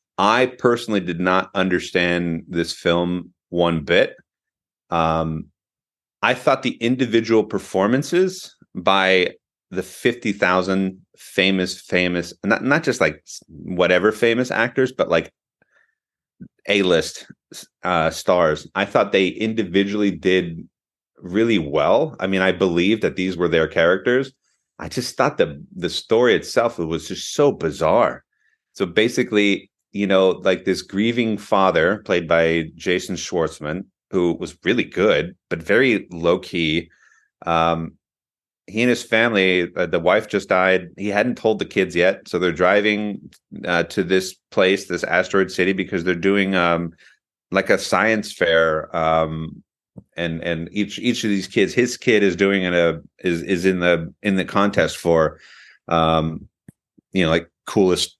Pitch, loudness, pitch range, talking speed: 95 Hz, -19 LUFS, 85-105 Hz, 145 wpm